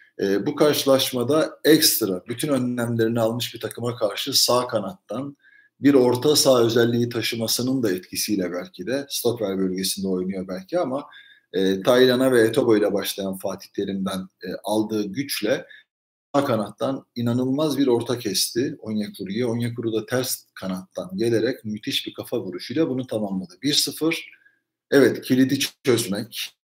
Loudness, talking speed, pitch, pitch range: -22 LUFS, 130 wpm, 120 Hz, 105-135 Hz